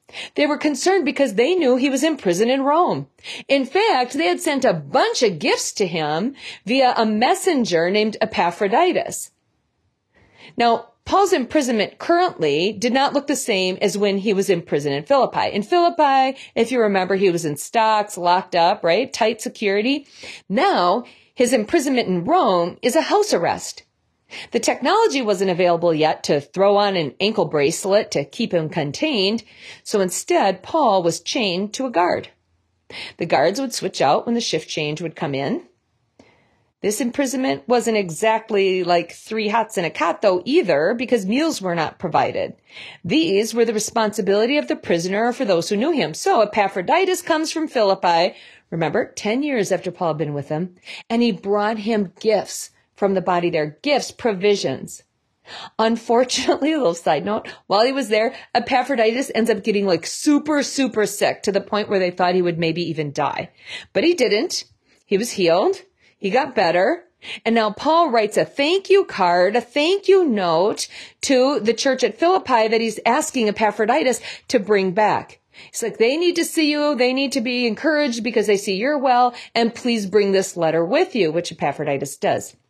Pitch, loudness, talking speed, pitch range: 225 Hz, -19 LUFS, 180 wpm, 190-275 Hz